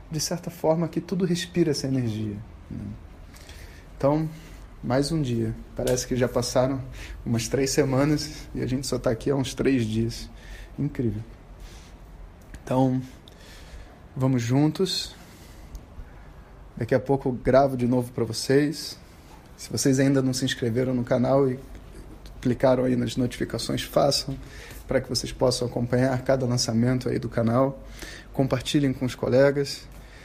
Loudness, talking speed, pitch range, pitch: -25 LUFS, 140 wpm, 115-135 Hz, 130 Hz